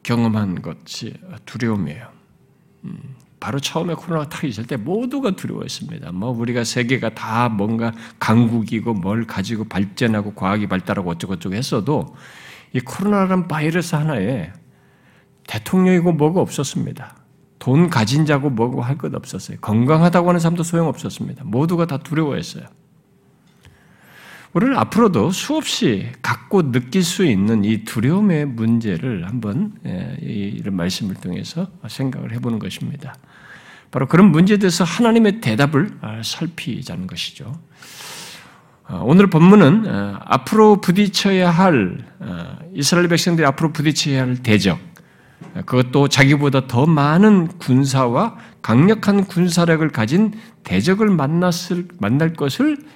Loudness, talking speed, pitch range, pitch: -18 LUFS, 300 characters per minute, 120-180 Hz, 150 Hz